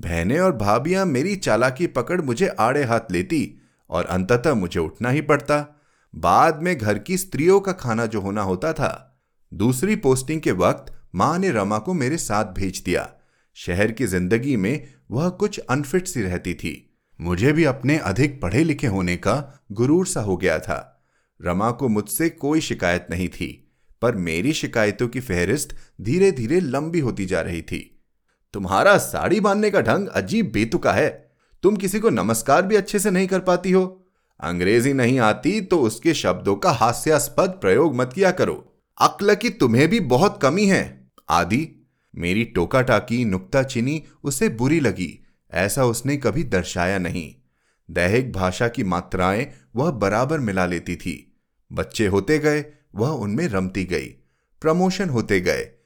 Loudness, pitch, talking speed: -21 LUFS, 125 Hz, 165 wpm